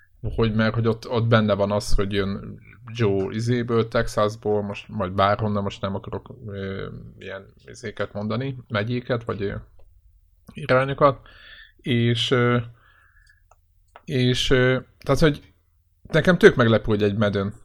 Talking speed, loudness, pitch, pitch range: 135 wpm, -22 LUFS, 110 Hz, 100-120 Hz